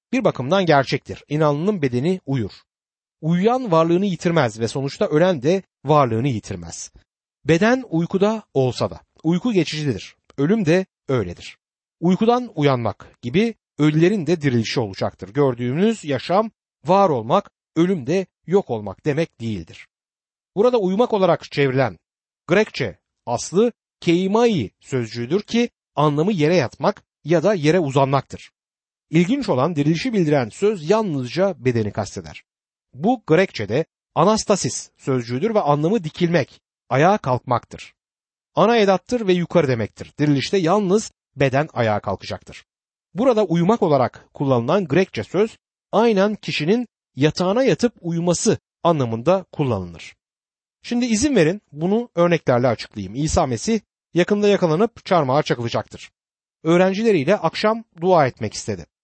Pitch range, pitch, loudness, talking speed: 130-195 Hz, 160 Hz, -20 LUFS, 115 wpm